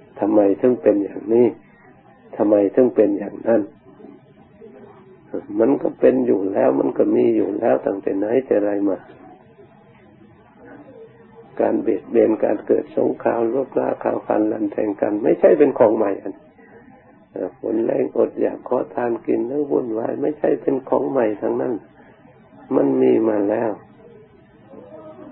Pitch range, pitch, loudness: 100-115 Hz, 110 Hz, -19 LUFS